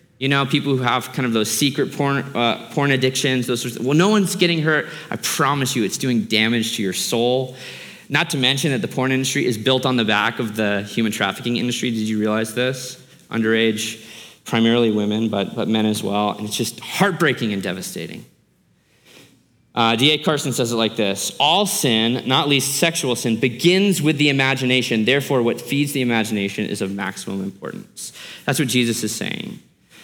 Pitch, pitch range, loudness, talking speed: 125 Hz, 110-140 Hz, -19 LUFS, 195 wpm